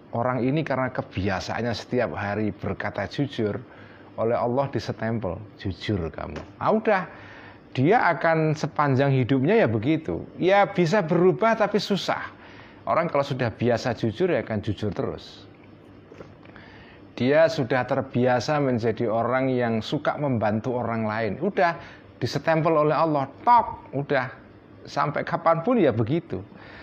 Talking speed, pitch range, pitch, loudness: 125 wpm, 110-155 Hz, 130 Hz, -24 LUFS